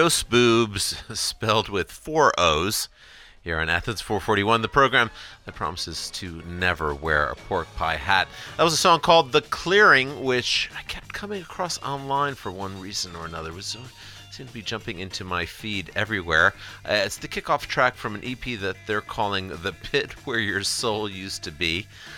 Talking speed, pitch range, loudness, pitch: 185 wpm, 90-125 Hz, -23 LUFS, 105 Hz